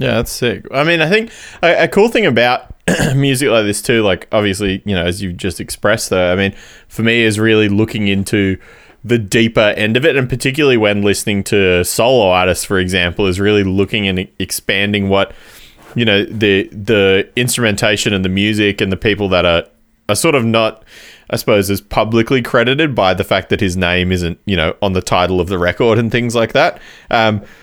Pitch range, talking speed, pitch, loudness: 95-115 Hz, 205 wpm, 105 Hz, -14 LUFS